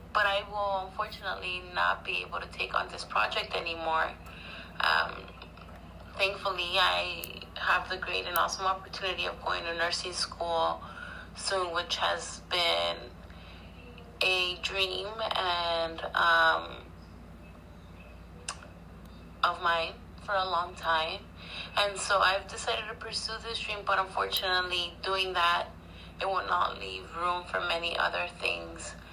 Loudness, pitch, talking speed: -30 LUFS, 165 Hz, 130 wpm